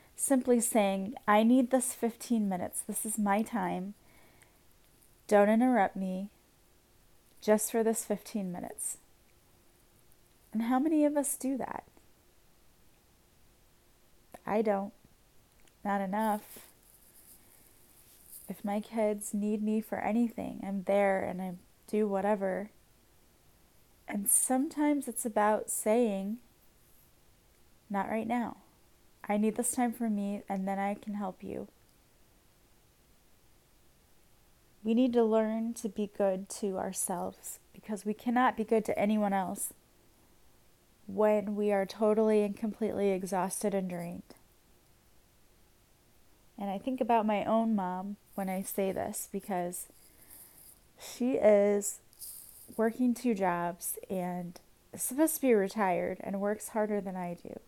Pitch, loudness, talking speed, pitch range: 210 Hz, -31 LUFS, 125 wpm, 195-225 Hz